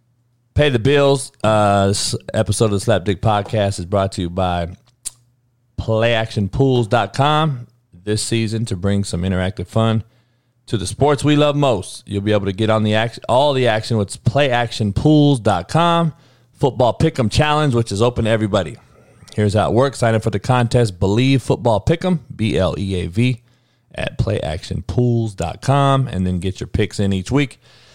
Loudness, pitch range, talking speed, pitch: -18 LUFS, 105-130 Hz, 160 wpm, 115 Hz